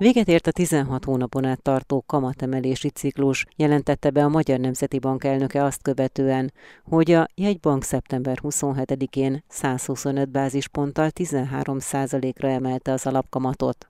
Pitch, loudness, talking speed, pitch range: 135 Hz, -23 LUFS, 125 wpm, 130-145 Hz